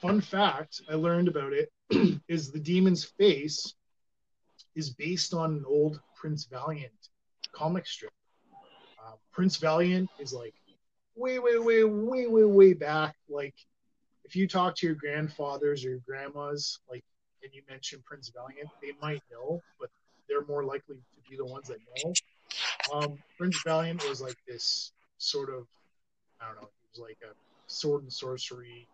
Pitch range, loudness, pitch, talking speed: 145-210 Hz, -29 LUFS, 160 Hz, 160 wpm